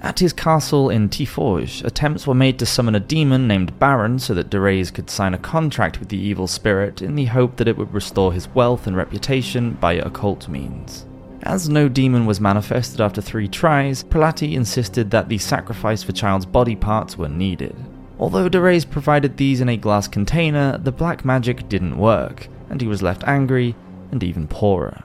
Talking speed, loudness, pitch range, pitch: 190 wpm, -19 LUFS, 100-135 Hz, 115 Hz